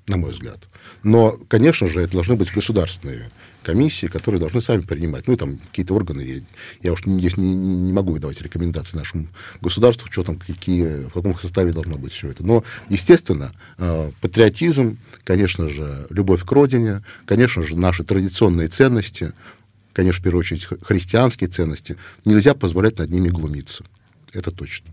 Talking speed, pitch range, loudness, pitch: 160 wpm, 85-110 Hz, -19 LUFS, 95 Hz